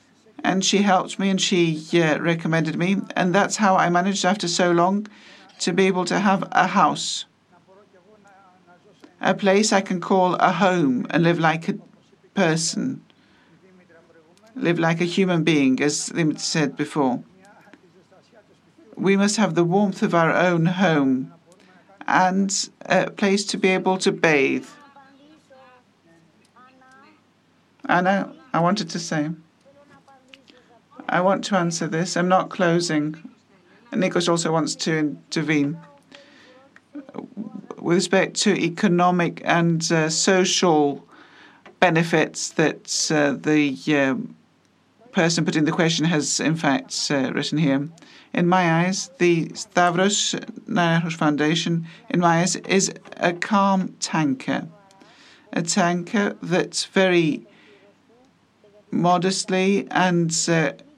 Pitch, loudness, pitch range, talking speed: 185 Hz, -21 LUFS, 165-205 Hz, 120 wpm